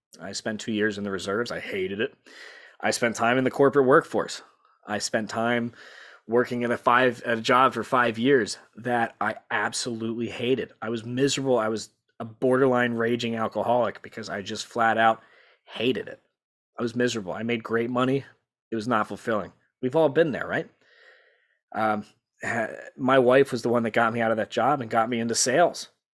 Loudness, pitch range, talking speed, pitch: -25 LUFS, 110-125 Hz, 195 wpm, 115 Hz